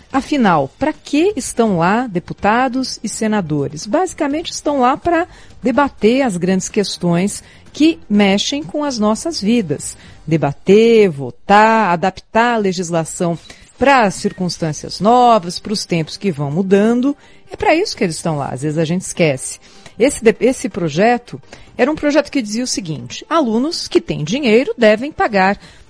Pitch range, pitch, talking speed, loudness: 175-265 Hz, 215 Hz, 150 wpm, -15 LUFS